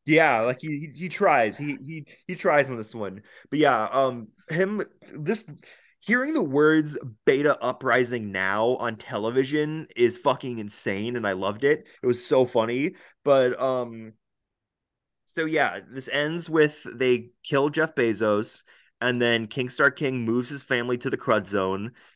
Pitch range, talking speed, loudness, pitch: 115-150 Hz, 155 wpm, -24 LUFS, 130 Hz